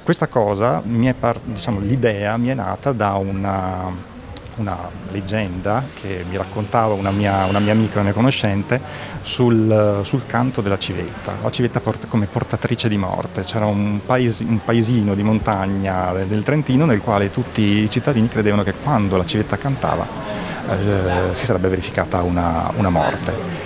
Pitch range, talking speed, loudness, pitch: 95-120 Hz, 150 wpm, -19 LUFS, 105 Hz